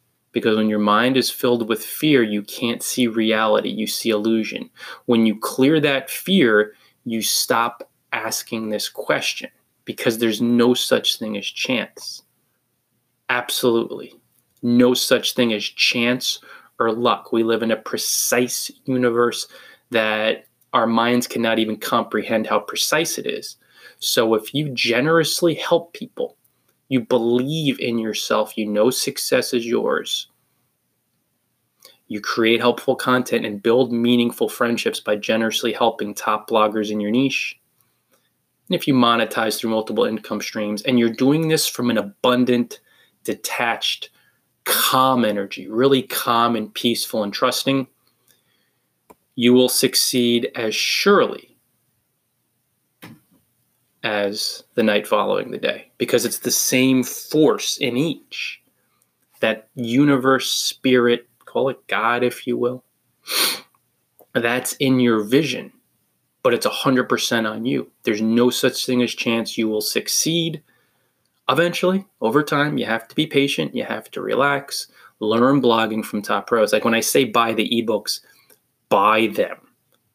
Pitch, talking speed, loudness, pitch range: 120 Hz, 140 wpm, -20 LUFS, 115-130 Hz